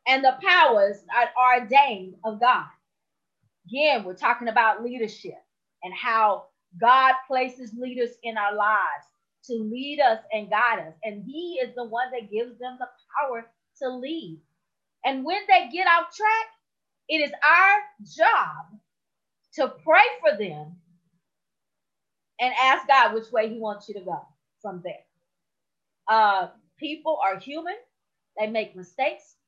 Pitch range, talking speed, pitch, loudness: 210-280 Hz, 145 wpm, 240 Hz, -22 LUFS